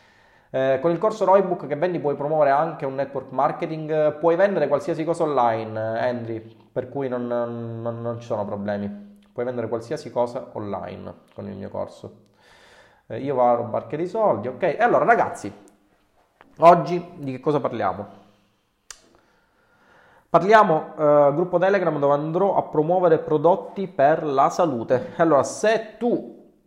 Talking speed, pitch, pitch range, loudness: 160 wpm, 145 Hz, 120-170 Hz, -22 LUFS